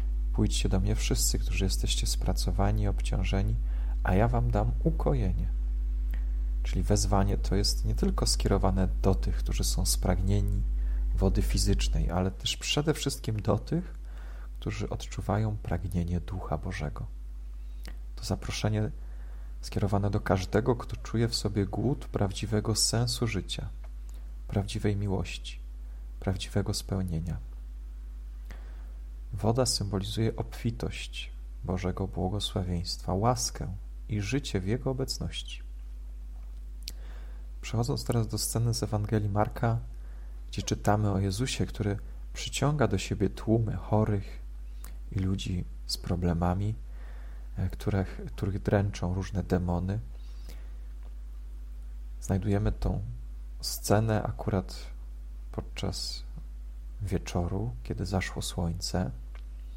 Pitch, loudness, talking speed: 95 Hz, -30 LUFS, 100 wpm